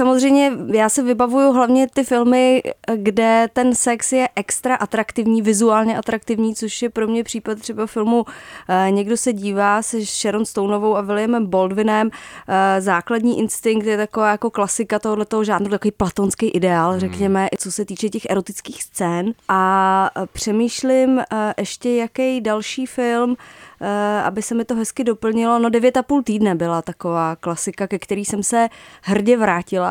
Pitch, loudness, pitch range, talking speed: 220 Hz, -18 LUFS, 200-235 Hz, 150 wpm